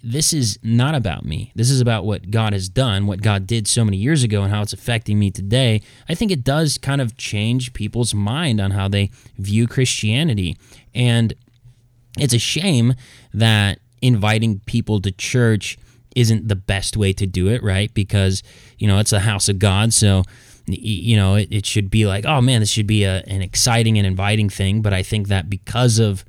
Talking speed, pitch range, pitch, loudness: 200 wpm, 100-120 Hz, 110 Hz, -18 LUFS